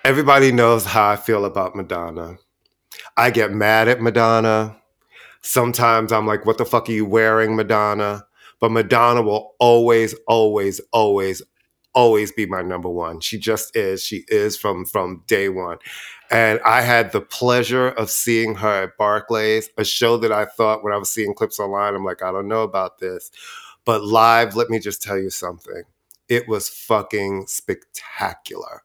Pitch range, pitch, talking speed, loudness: 105-115 Hz, 110 Hz, 170 wpm, -18 LUFS